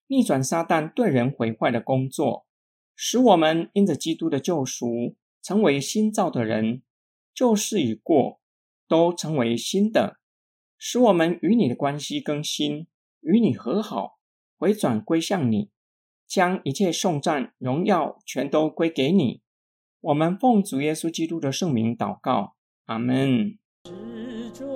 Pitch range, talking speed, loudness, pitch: 125-200 Hz, 200 characters per minute, -23 LUFS, 160 Hz